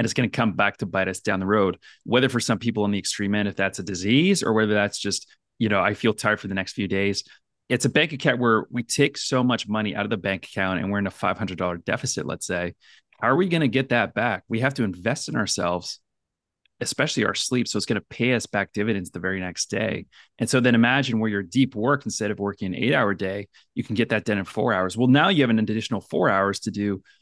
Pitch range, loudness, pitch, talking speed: 100-120 Hz, -23 LUFS, 105 Hz, 275 wpm